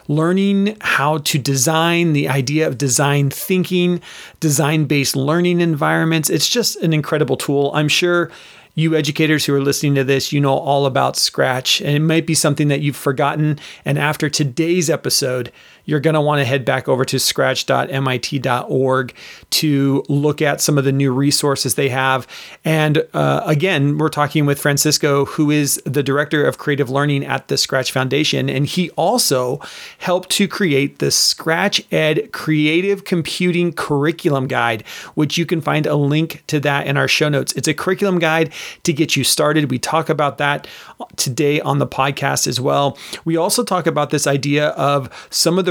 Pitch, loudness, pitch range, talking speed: 150 Hz, -17 LUFS, 140-160 Hz, 175 wpm